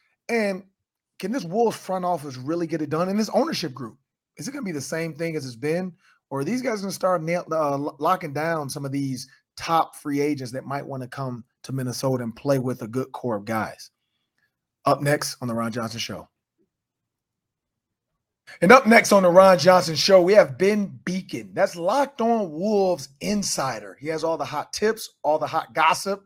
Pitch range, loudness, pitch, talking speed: 140-195 Hz, -22 LUFS, 165 Hz, 210 wpm